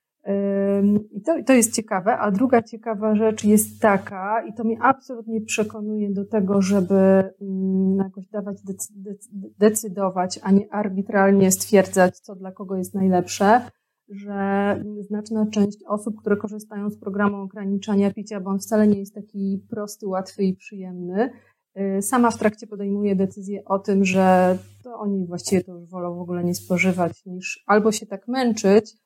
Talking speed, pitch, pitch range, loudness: 155 wpm, 200 Hz, 195-215 Hz, -22 LUFS